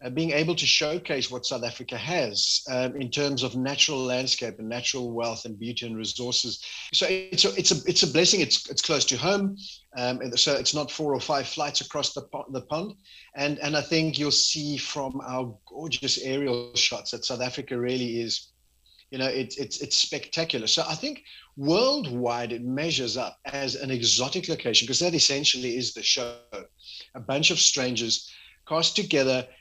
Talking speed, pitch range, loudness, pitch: 190 wpm, 125-150 Hz, -25 LUFS, 135 Hz